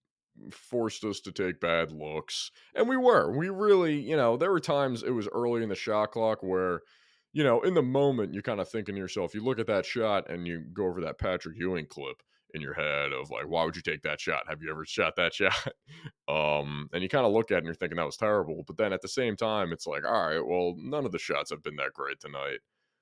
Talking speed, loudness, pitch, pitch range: 260 wpm, -30 LUFS, 105 Hz, 85-140 Hz